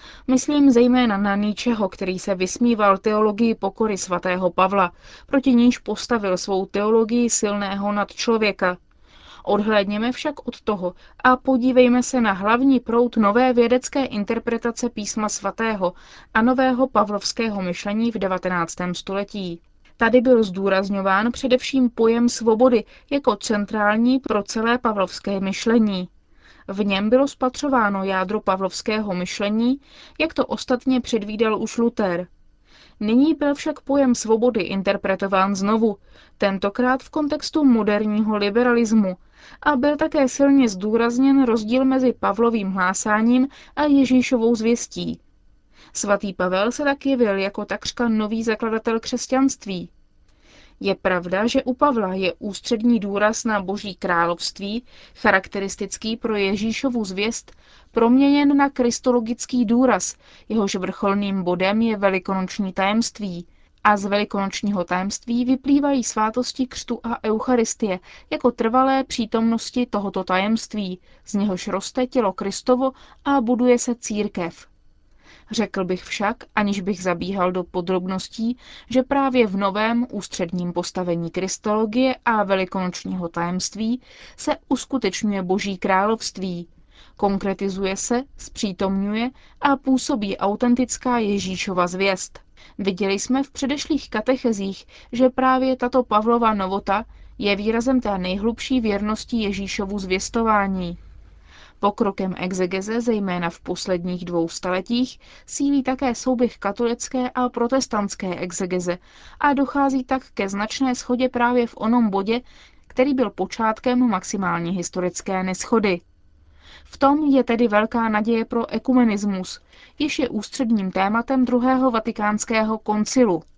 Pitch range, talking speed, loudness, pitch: 195-250 Hz, 115 wpm, -21 LUFS, 220 Hz